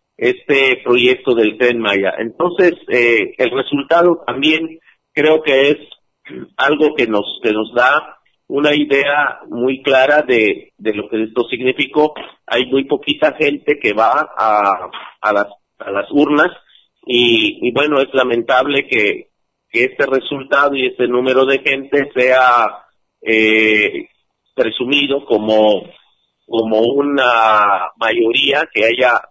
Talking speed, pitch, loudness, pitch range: 130 wpm, 140 Hz, -14 LUFS, 120-155 Hz